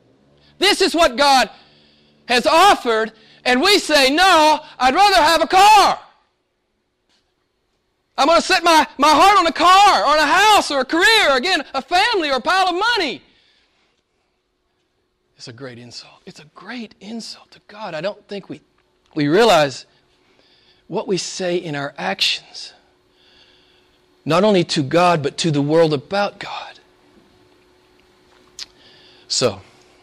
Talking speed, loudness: 145 wpm, -15 LUFS